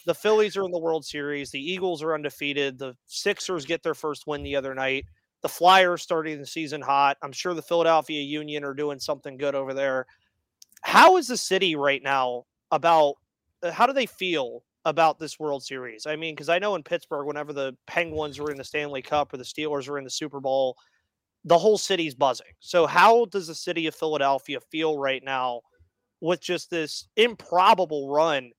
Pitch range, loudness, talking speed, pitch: 140-170 Hz, -24 LUFS, 195 wpm, 150 Hz